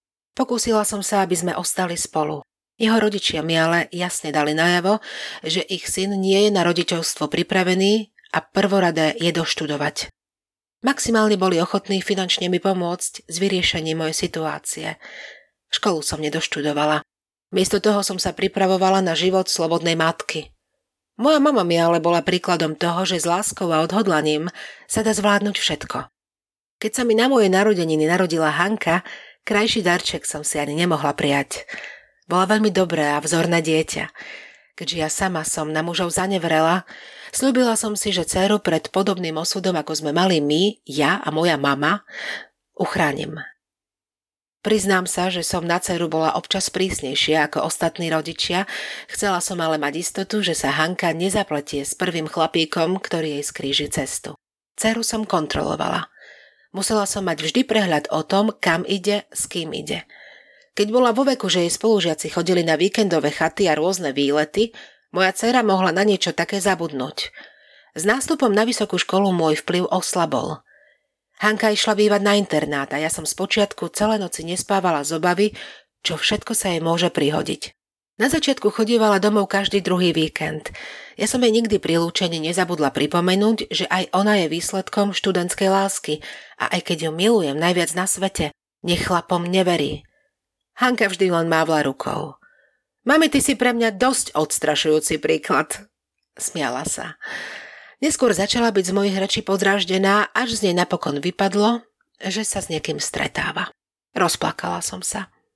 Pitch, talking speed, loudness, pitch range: 180 Hz, 155 wpm, -20 LUFS, 160-205 Hz